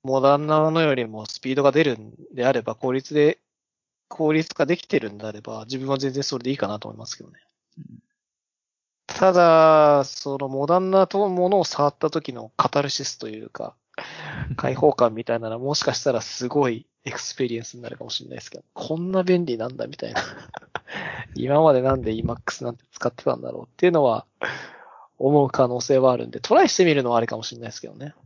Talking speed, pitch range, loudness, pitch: 405 characters per minute, 120-155 Hz, -22 LUFS, 135 Hz